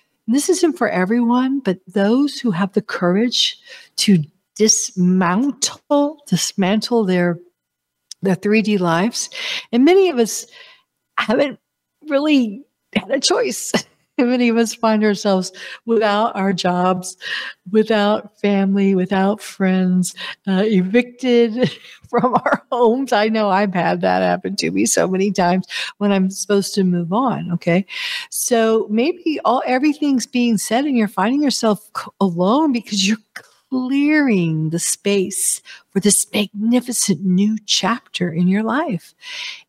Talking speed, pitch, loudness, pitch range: 130 wpm, 215 Hz, -18 LUFS, 190-250 Hz